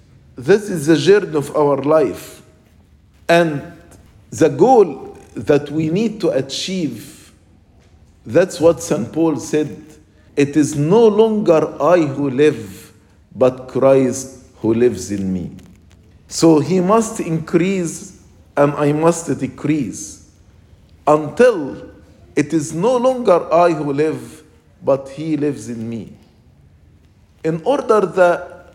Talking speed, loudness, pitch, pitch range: 120 wpm, -16 LUFS, 150 Hz, 110-170 Hz